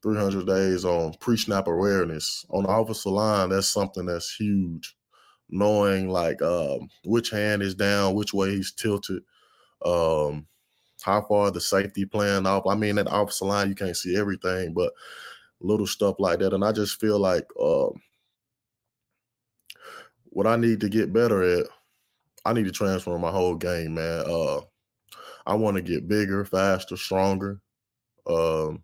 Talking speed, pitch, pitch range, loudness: 160 wpm, 100 Hz, 95-105 Hz, -25 LUFS